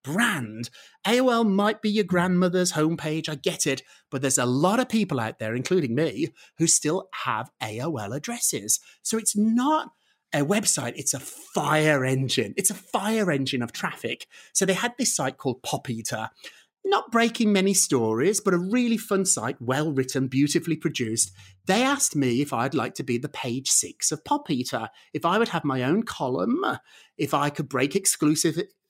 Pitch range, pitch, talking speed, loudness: 130-210 Hz, 160 Hz, 180 wpm, -24 LUFS